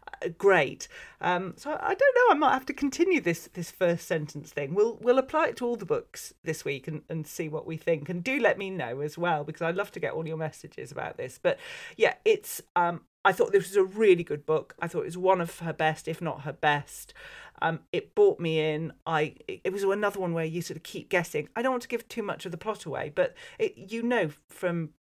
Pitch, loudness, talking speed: 180 Hz, -28 LUFS, 250 wpm